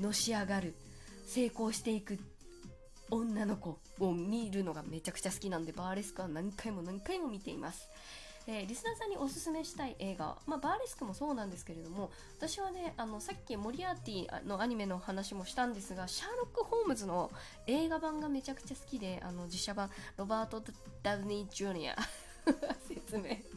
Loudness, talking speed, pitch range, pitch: -39 LUFS, 380 characters per minute, 190-275 Hz, 210 Hz